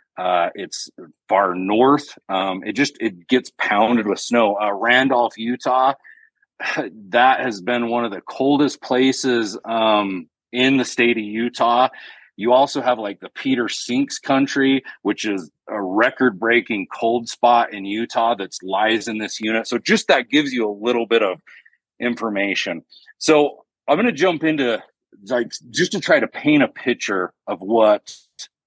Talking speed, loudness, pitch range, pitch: 160 wpm, -19 LUFS, 110-135 Hz, 120 Hz